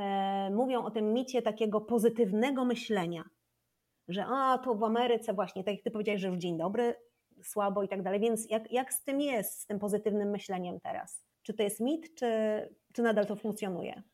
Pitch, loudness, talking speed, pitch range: 215 Hz, -32 LUFS, 190 wpm, 200-235 Hz